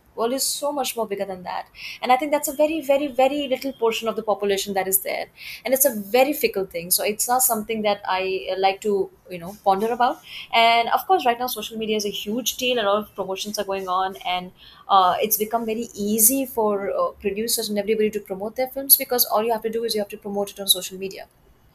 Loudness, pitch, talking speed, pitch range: -22 LUFS, 215 Hz, 250 wpm, 195-250 Hz